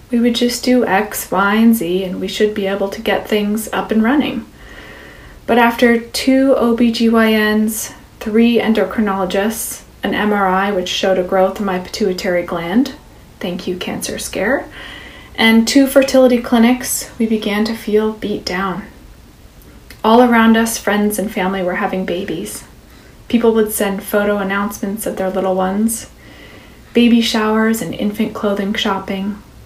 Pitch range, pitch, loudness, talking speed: 195-230 Hz, 215 Hz, -15 LUFS, 150 wpm